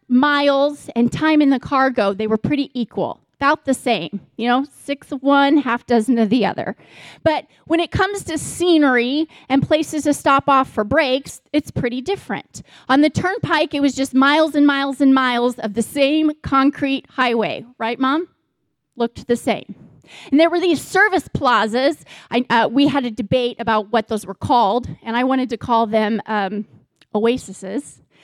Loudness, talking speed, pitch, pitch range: -18 LUFS, 180 wpm, 265 Hz, 235-290 Hz